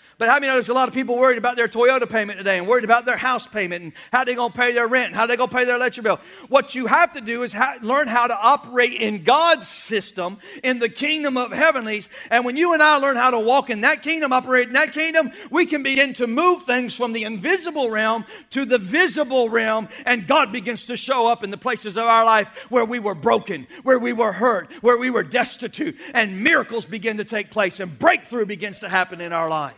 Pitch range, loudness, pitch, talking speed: 220-270 Hz, -19 LUFS, 245 Hz, 255 wpm